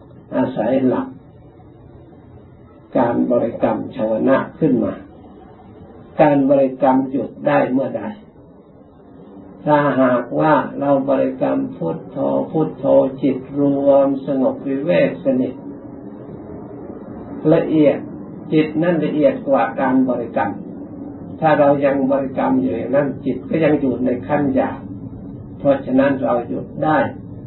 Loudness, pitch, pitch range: -18 LUFS, 140 Hz, 115-150 Hz